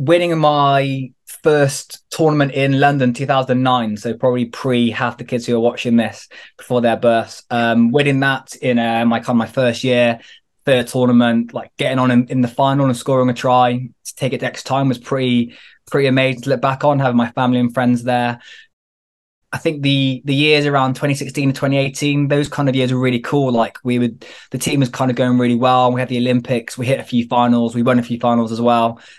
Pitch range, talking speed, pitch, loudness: 120-135 Hz, 220 wpm, 125 Hz, -16 LUFS